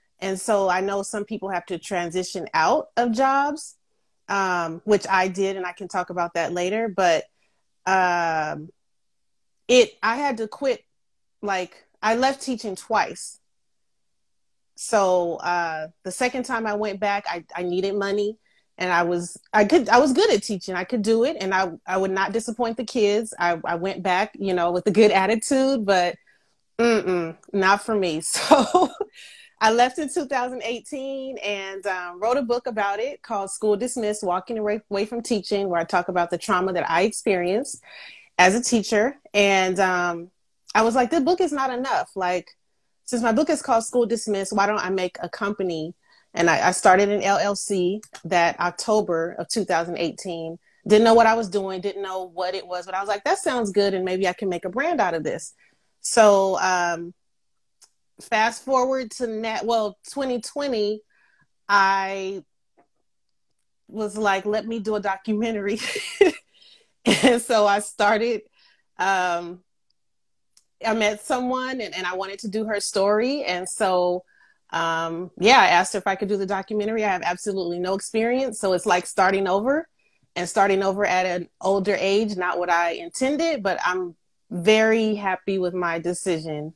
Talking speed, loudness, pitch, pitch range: 170 wpm, -22 LUFS, 200 Hz, 180-230 Hz